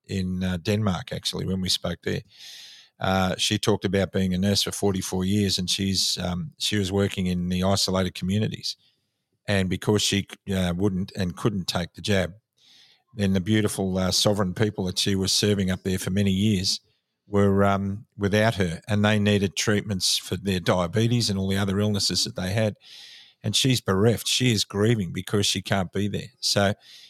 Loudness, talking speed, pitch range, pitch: -24 LUFS, 185 wpm, 95-105 Hz, 100 Hz